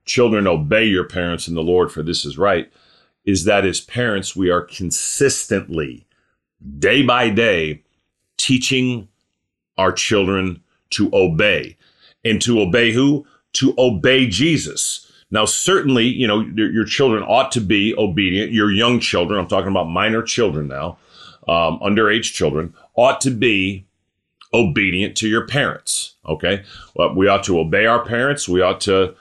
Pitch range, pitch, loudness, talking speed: 90-120 Hz, 100 Hz, -17 LUFS, 150 wpm